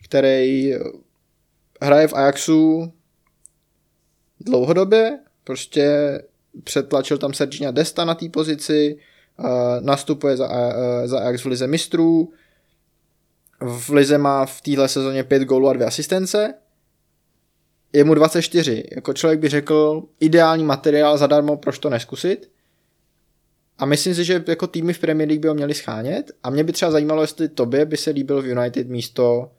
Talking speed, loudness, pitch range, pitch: 140 wpm, -19 LUFS, 135-160 Hz, 150 Hz